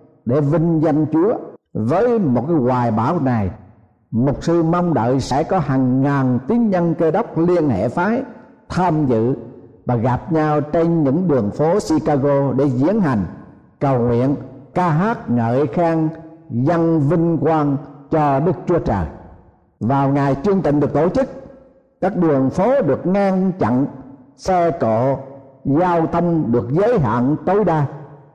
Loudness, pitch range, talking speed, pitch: -18 LUFS, 130-170 Hz, 155 wpm, 145 Hz